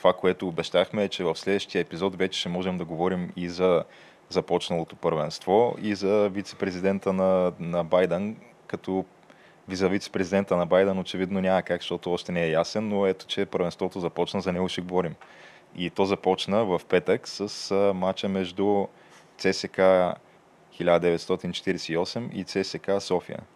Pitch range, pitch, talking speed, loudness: 90-100 Hz, 95 Hz, 150 wpm, -26 LUFS